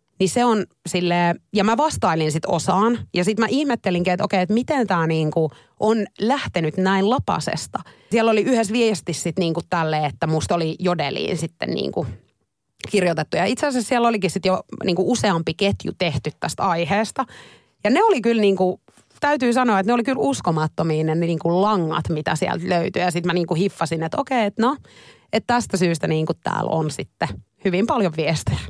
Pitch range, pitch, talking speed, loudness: 165-225 Hz, 185 Hz, 180 wpm, -21 LUFS